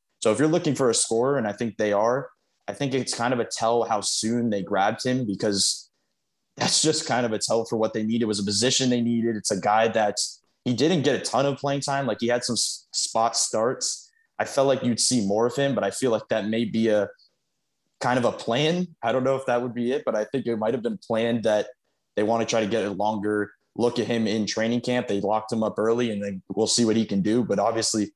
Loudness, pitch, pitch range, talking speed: -24 LUFS, 115 Hz, 105-125 Hz, 265 wpm